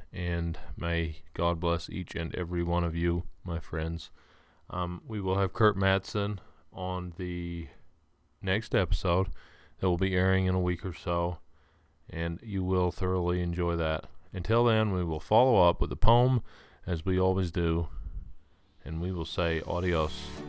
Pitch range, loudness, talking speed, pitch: 85-95 Hz, -30 LUFS, 160 wpm, 85 Hz